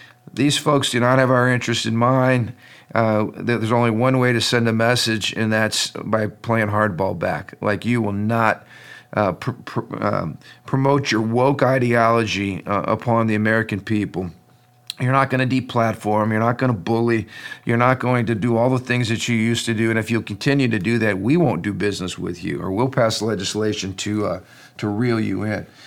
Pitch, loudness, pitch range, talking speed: 115 Hz, -20 LUFS, 105-125 Hz, 205 wpm